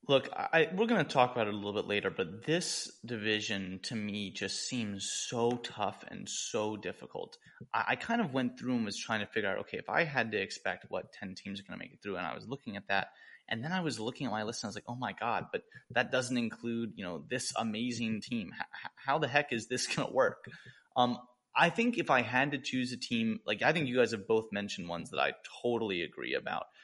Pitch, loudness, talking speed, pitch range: 120 Hz, -34 LUFS, 255 wpm, 110-135 Hz